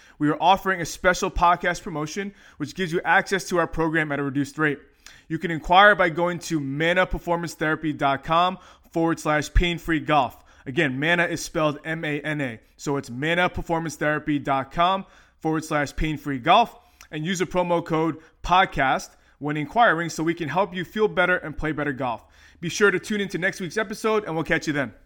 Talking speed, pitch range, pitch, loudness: 180 wpm, 150-180 Hz, 165 Hz, -23 LUFS